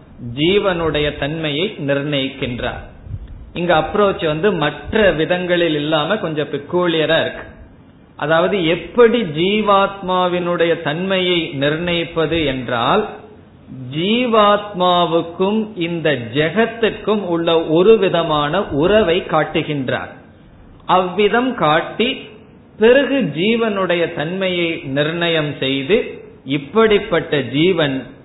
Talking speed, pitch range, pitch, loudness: 70 wpm, 150-195 Hz, 170 Hz, -16 LUFS